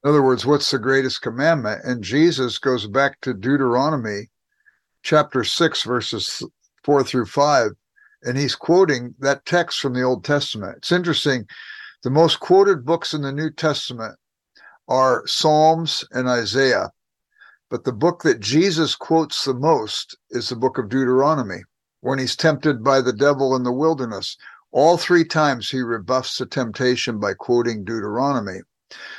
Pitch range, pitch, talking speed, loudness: 125-155 Hz, 135 Hz, 150 wpm, -20 LUFS